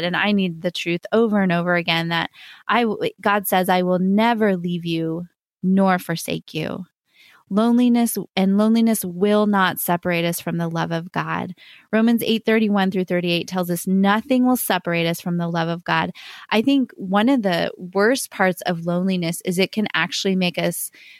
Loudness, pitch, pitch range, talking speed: -20 LUFS, 190 Hz, 175-215 Hz, 180 wpm